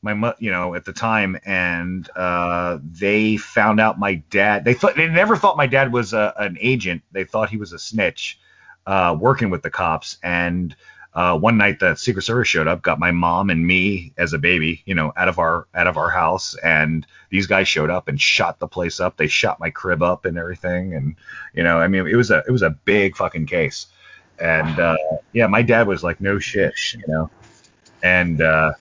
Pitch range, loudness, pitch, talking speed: 85-110 Hz, -18 LUFS, 95 Hz, 220 wpm